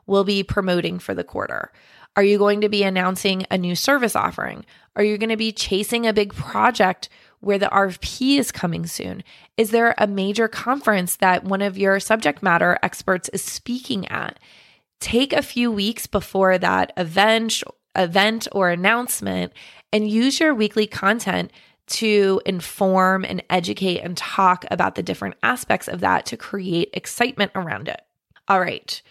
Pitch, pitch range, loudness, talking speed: 200 Hz, 185-220 Hz, -20 LUFS, 165 wpm